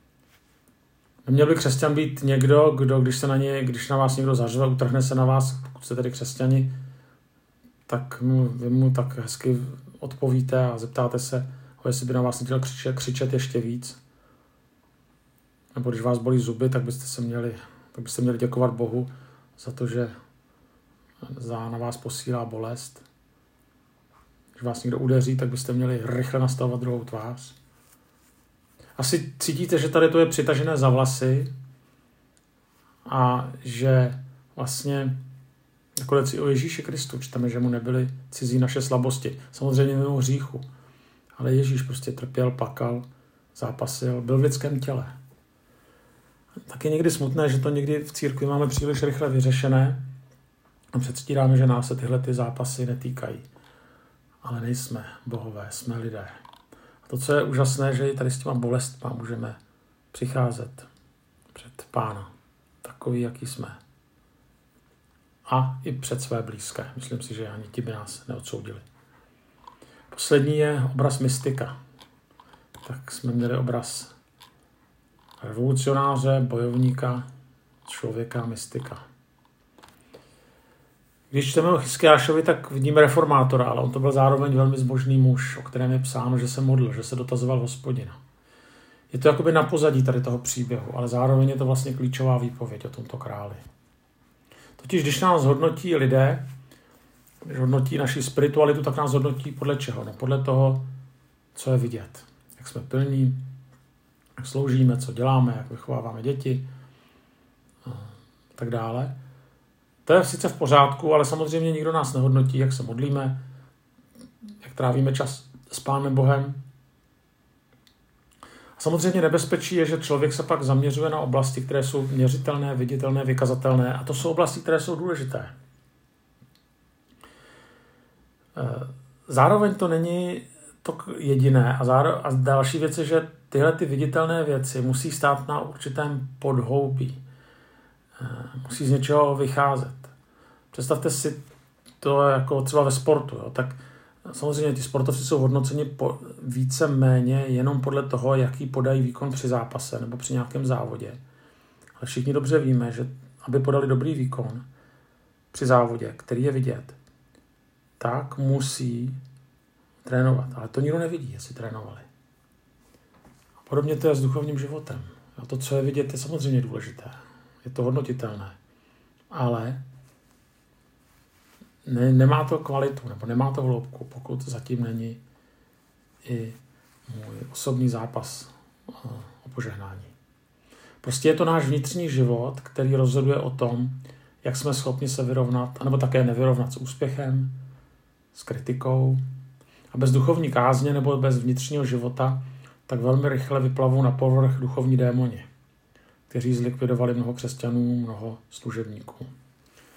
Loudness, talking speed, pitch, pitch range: -24 LUFS, 135 wpm, 130 Hz, 125-140 Hz